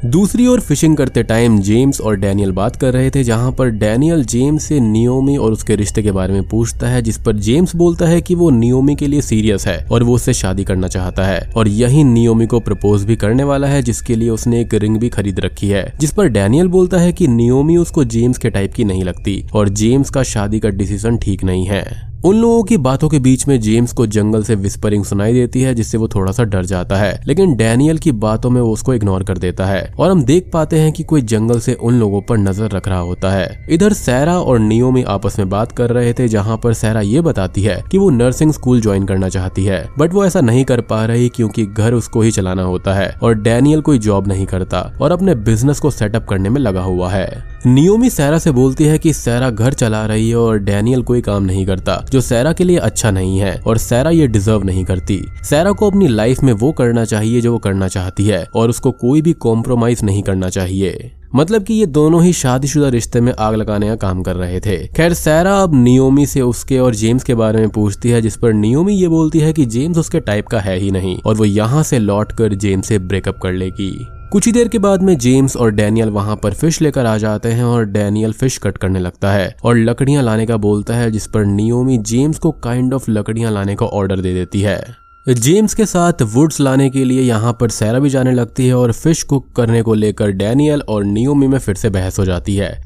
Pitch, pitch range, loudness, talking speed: 115 Hz, 105-135 Hz, -14 LUFS, 235 wpm